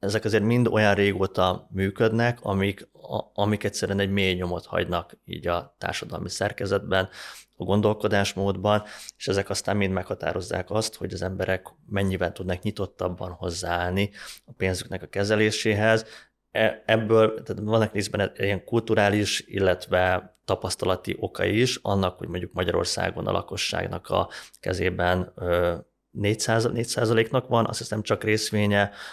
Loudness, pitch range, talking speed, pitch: -25 LUFS, 95-110 Hz, 130 wpm, 100 Hz